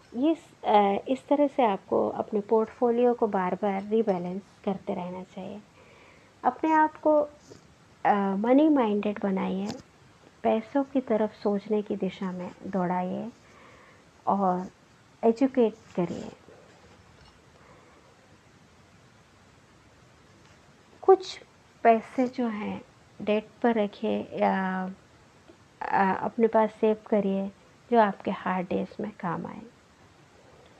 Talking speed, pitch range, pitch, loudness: 95 wpm, 195-240 Hz, 215 Hz, -27 LUFS